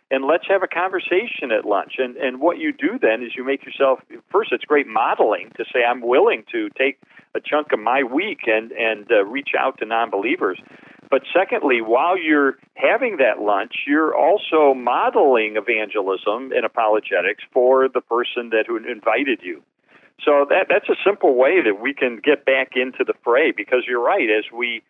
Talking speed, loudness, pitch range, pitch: 190 wpm, -19 LUFS, 120-195 Hz, 135 Hz